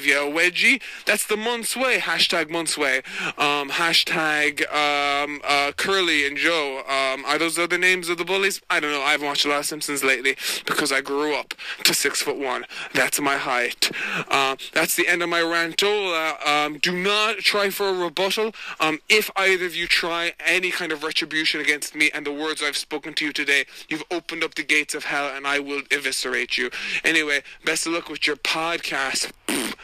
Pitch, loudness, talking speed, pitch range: 155 Hz, -21 LUFS, 200 wpm, 145-175 Hz